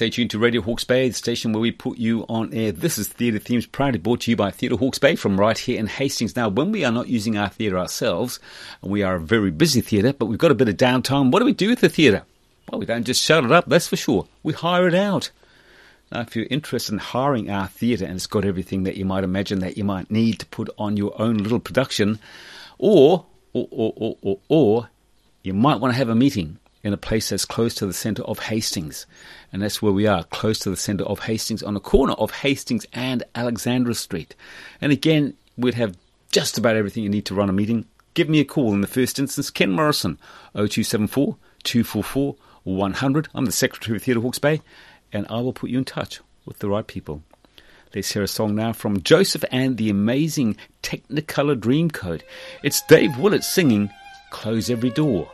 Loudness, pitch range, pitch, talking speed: -21 LUFS, 100-130 Hz, 115 Hz, 225 wpm